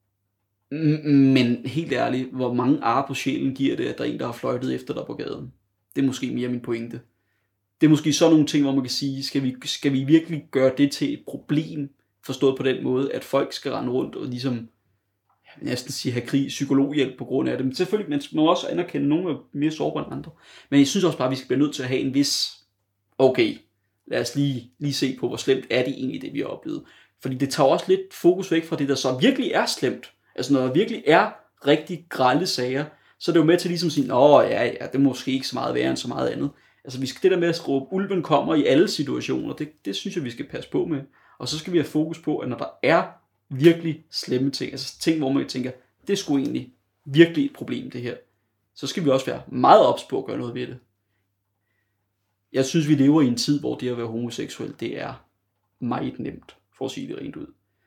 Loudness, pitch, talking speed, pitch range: -23 LUFS, 135 Hz, 250 wpm, 125-155 Hz